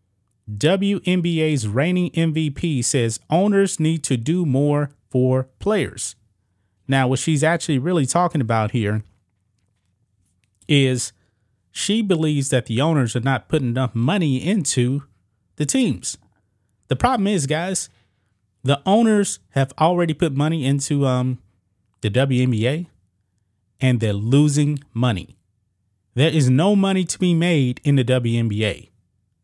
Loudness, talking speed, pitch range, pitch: -20 LUFS, 125 wpm, 105-160 Hz, 130 Hz